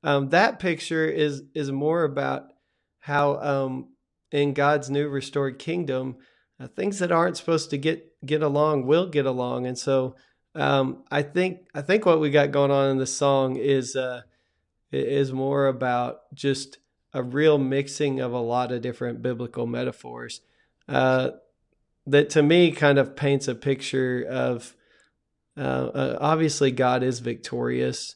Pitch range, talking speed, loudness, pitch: 125-150 Hz, 155 wpm, -24 LUFS, 140 Hz